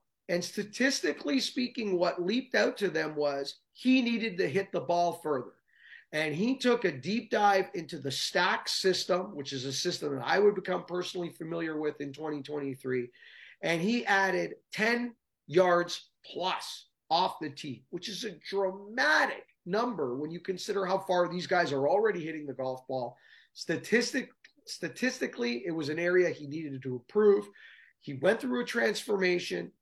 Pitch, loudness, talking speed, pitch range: 180 Hz, -30 LUFS, 165 wpm, 150-205 Hz